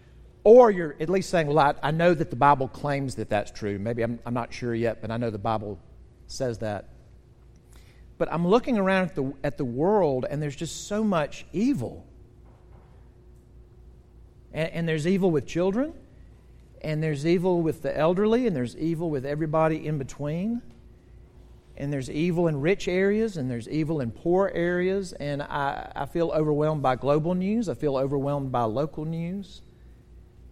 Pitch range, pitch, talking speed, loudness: 135-175 Hz, 155 Hz, 175 wpm, -25 LUFS